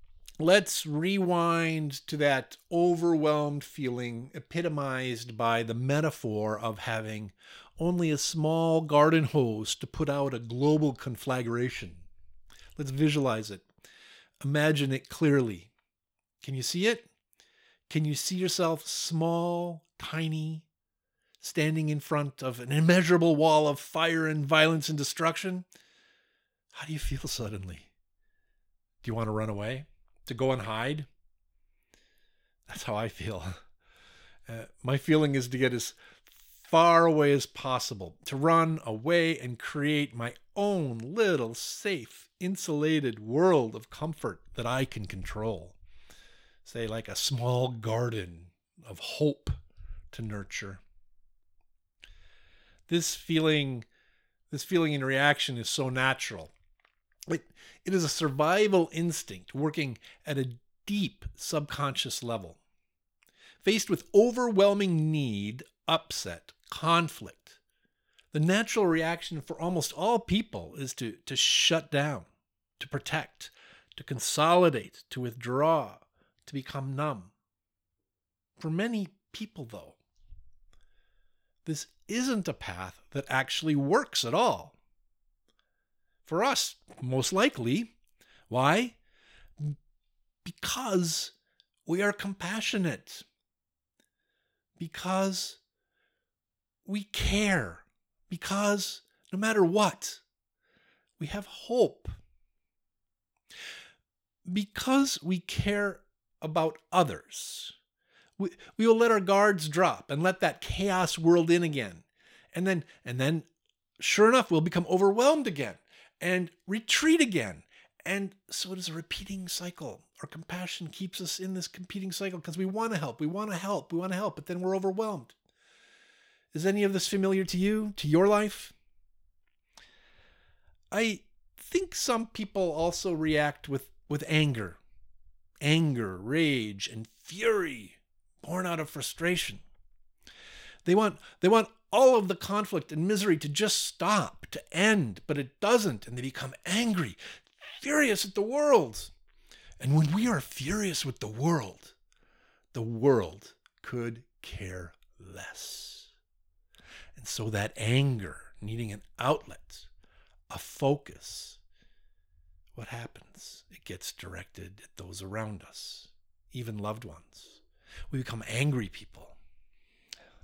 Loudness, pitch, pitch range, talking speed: -29 LUFS, 150 Hz, 110-180 Hz, 120 wpm